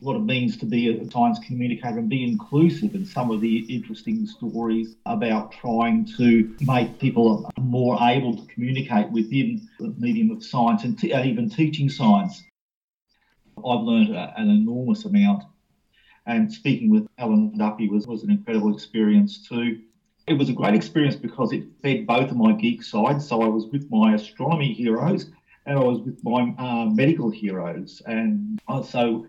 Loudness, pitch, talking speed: -22 LUFS, 135 Hz, 170 wpm